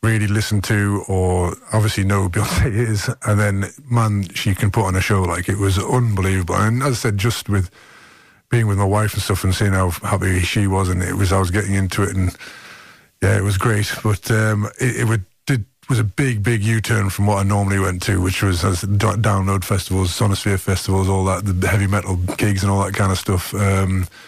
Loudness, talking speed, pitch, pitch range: -19 LUFS, 225 wpm, 100 Hz, 95-110 Hz